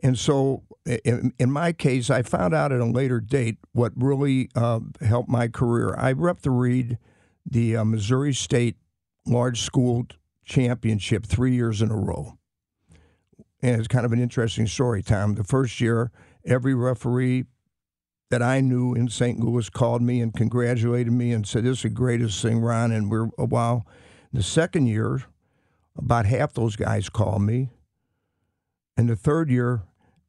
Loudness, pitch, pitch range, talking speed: -23 LUFS, 120 Hz, 110-125 Hz, 165 wpm